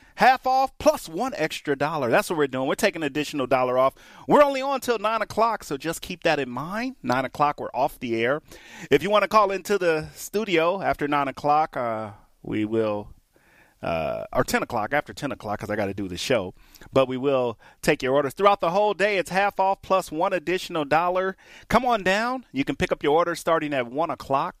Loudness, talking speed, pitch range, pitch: -24 LUFS, 225 wpm, 135-205 Hz, 160 Hz